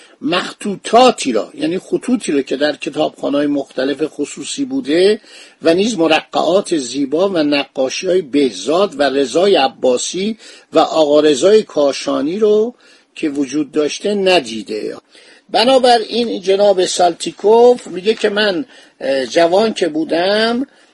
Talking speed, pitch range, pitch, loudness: 115 wpm, 150-235 Hz, 190 Hz, -15 LUFS